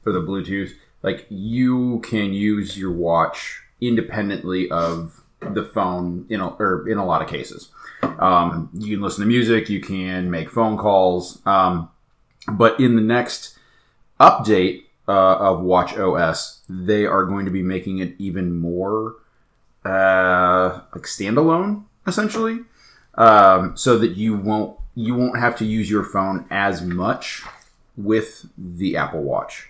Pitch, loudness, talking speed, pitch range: 100 Hz, -19 LUFS, 145 wpm, 90-115 Hz